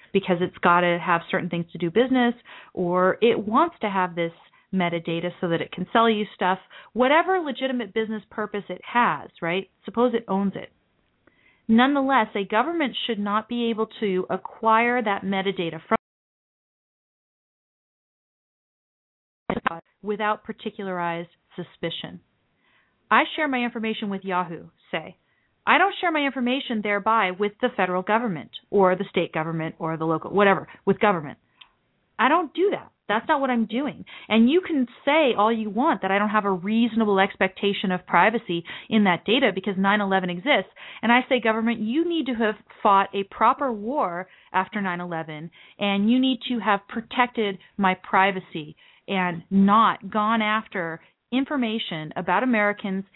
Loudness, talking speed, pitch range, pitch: -23 LUFS, 155 wpm, 185-235 Hz, 205 Hz